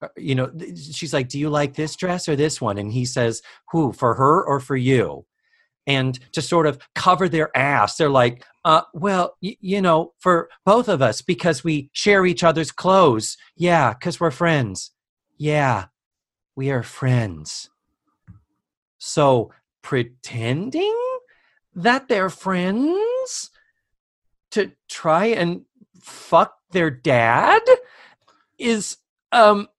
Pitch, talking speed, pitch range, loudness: 165 Hz, 135 wpm, 135-195 Hz, -20 LUFS